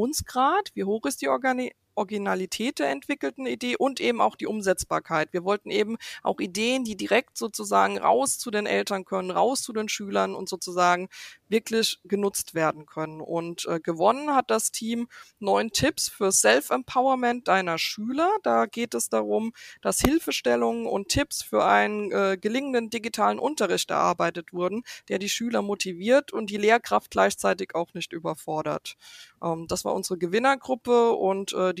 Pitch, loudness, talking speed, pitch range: 200 Hz, -25 LUFS, 160 wpm, 165-235 Hz